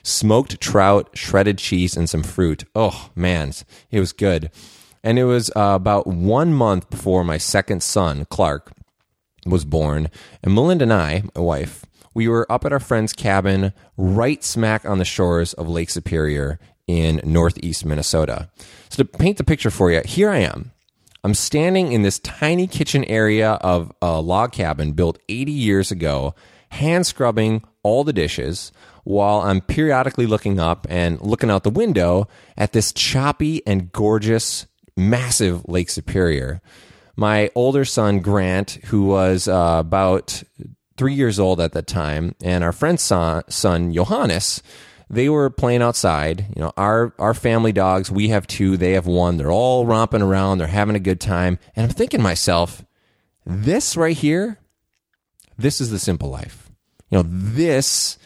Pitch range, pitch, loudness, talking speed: 90-115 Hz, 100 Hz, -19 LUFS, 165 wpm